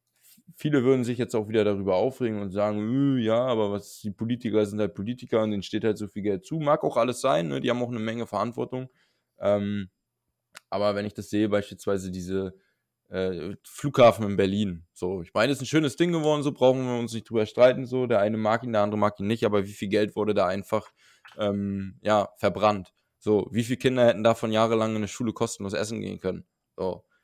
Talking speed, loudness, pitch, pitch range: 220 wpm, -26 LUFS, 110 Hz, 100-120 Hz